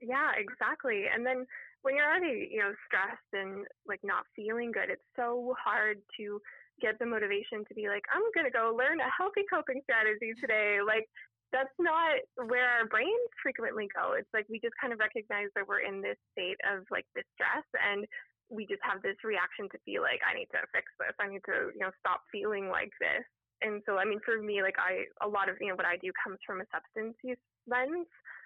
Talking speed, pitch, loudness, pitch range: 215 wpm, 225 Hz, -33 LUFS, 210-265 Hz